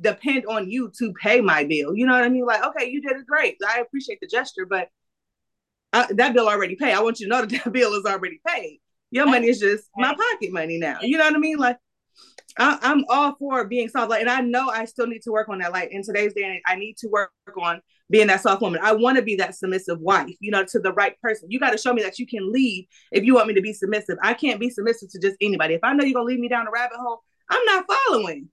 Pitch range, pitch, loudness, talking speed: 195-255 Hz, 225 Hz, -21 LUFS, 280 wpm